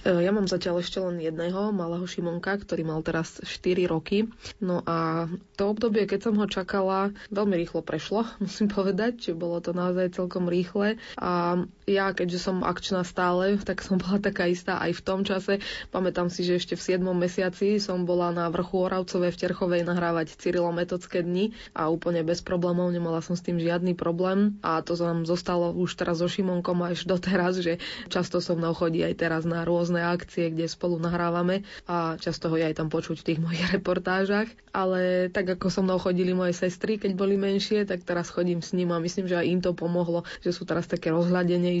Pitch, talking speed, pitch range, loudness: 180 Hz, 195 wpm, 170-190 Hz, -27 LUFS